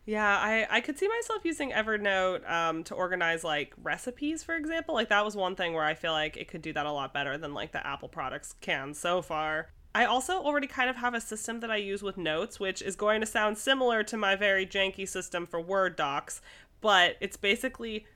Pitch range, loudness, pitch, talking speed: 175-230 Hz, -30 LUFS, 200 Hz, 230 wpm